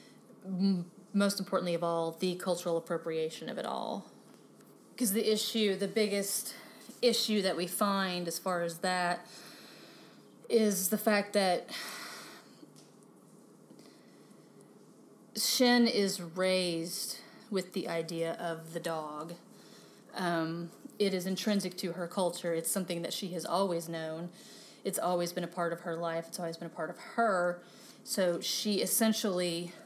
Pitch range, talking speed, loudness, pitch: 170-210 Hz, 135 wpm, -33 LUFS, 185 Hz